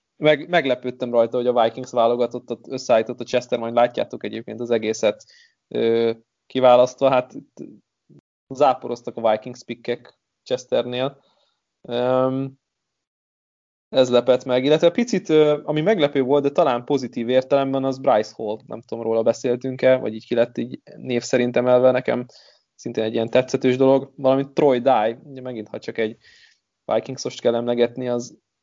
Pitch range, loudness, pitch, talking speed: 120-135 Hz, -21 LUFS, 125 Hz, 140 wpm